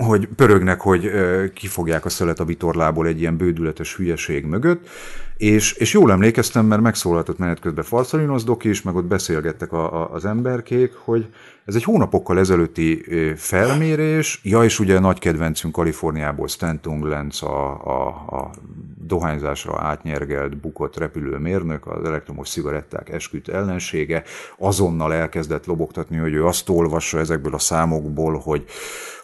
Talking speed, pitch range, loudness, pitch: 140 wpm, 80-100 Hz, -20 LUFS, 85 Hz